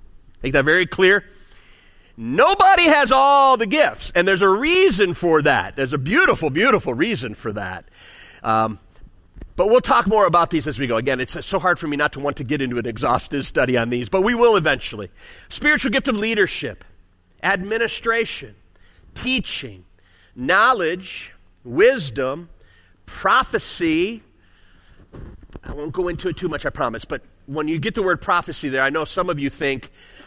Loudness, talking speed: -19 LUFS, 170 wpm